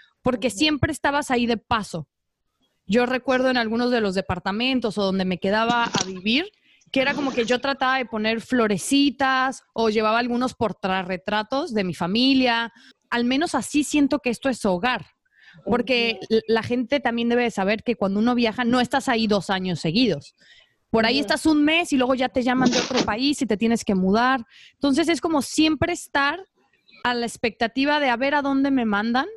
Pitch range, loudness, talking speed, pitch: 220-270 Hz, -22 LUFS, 190 wpm, 245 Hz